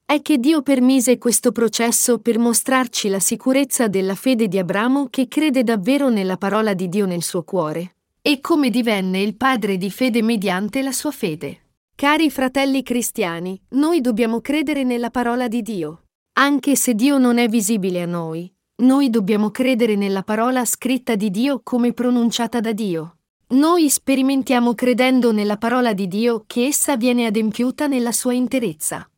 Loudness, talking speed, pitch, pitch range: -18 LUFS, 160 wpm, 240 Hz, 210-260 Hz